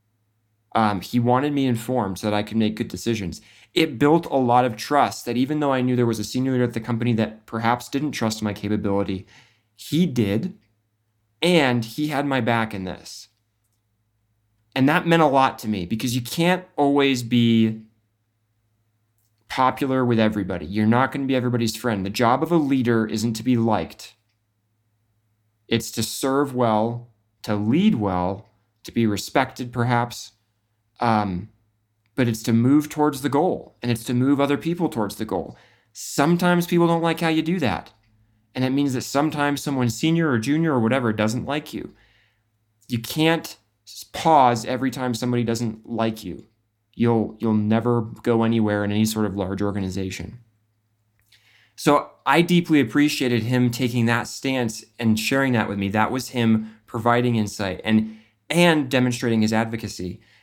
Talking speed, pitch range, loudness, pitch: 170 wpm, 110-130 Hz, -22 LUFS, 115 Hz